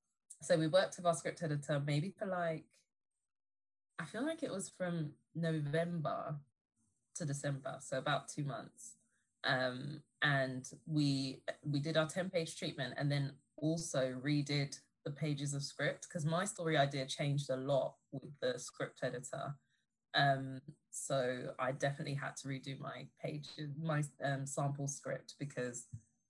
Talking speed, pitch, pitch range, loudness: 145 wpm, 145 Hz, 135-160 Hz, -39 LUFS